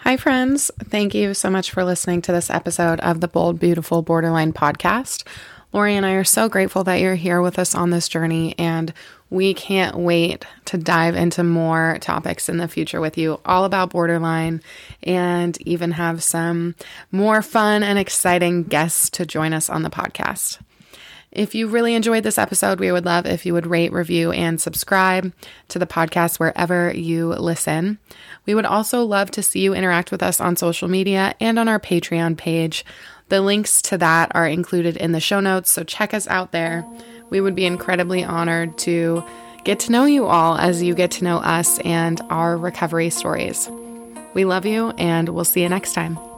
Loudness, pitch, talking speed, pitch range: -19 LUFS, 175 Hz, 190 wpm, 165-190 Hz